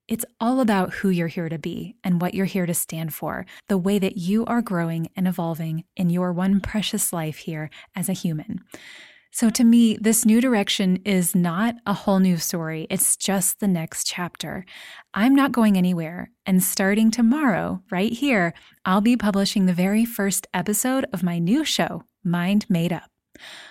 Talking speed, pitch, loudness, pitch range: 180 wpm, 195 Hz, -22 LUFS, 175-220 Hz